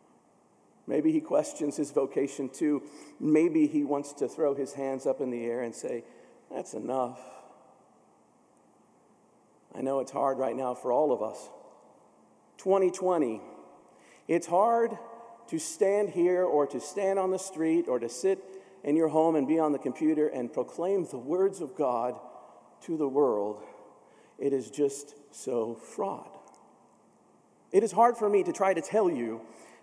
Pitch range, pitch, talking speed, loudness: 135-190 Hz, 155 Hz, 155 wpm, -29 LUFS